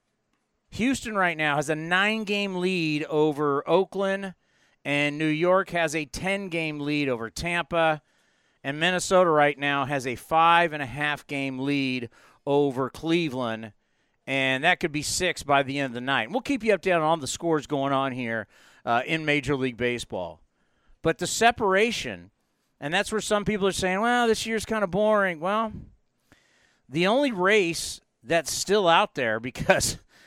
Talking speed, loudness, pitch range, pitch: 170 wpm, -25 LUFS, 140-190 Hz, 160 Hz